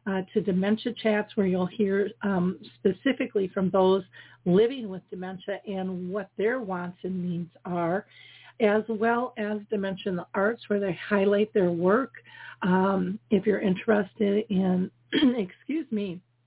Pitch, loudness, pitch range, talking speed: 200 Hz, -27 LUFS, 185-215 Hz, 145 wpm